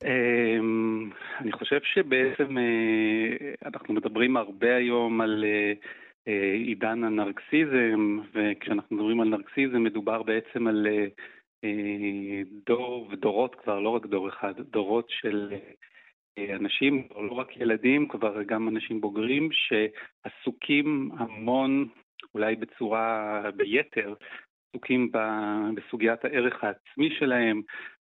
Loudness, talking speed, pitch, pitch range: -27 LUFS, 95 wpm, 110 Hz, 105-125 Hz